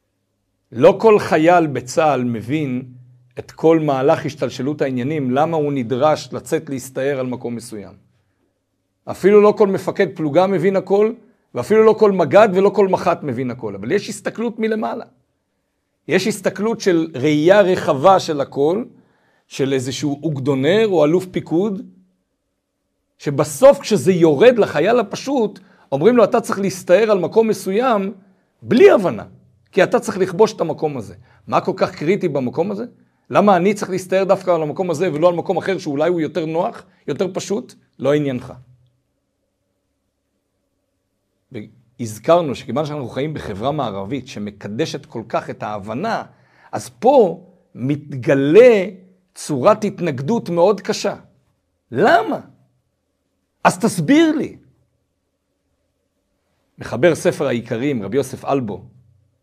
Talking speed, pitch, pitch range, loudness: 130 wpm, 160 Hz, 125-195 Hz, -17 LUFS